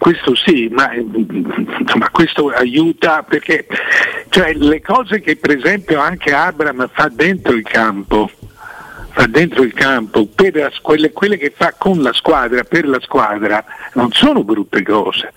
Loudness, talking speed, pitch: -13 LUFS, 150 wpm, 155 Hz